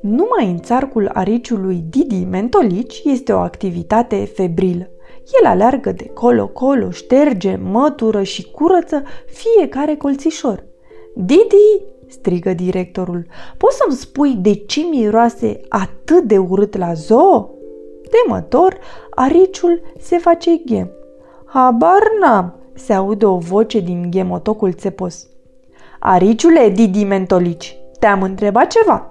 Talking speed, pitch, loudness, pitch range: 110 wpm, 225 Hz, -14 LUFS, 190-320 Hz